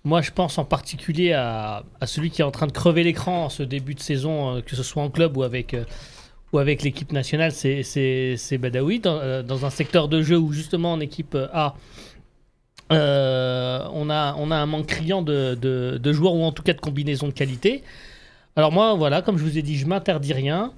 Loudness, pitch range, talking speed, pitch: -23 LUFS, 135-160 Hz, 220 wpm, 150 Hz